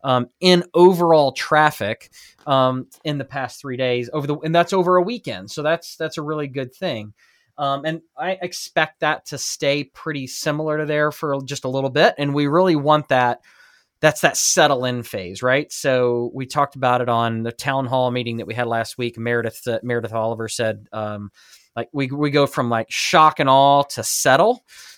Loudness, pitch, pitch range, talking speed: -19 LUFS, 140 Hz, 120-155 Hz, 200 wpm